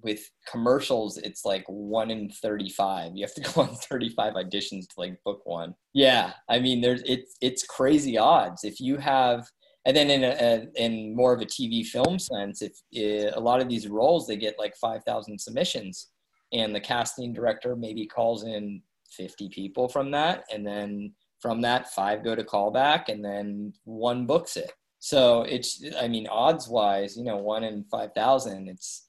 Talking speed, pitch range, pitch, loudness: 190 wpm, 105-125 Hz, 110 Hz, -26 LUFS